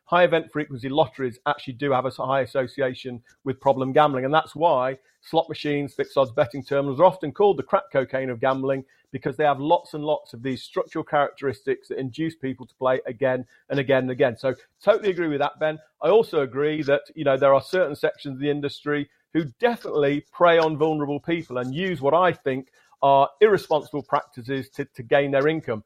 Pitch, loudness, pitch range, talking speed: 145 Hz, -23 LUFS, 135-160 Hz, 205 wpm